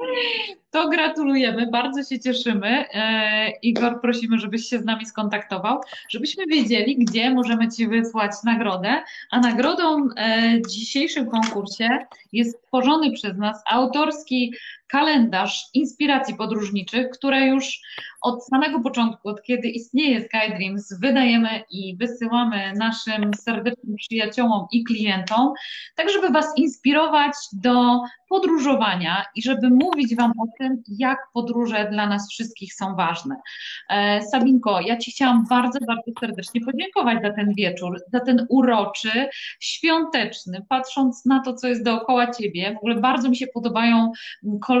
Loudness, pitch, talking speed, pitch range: -21 LUFS, 240 Hz, 135 wpm, 220-265 Hz